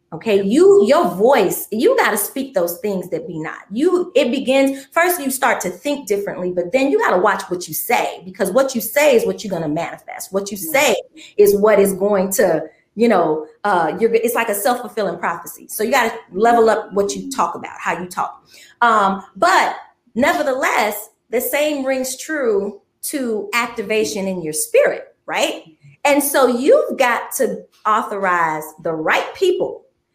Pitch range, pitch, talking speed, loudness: 195-270 Hz, 225 Hz, 185 wpm, -17 LUFS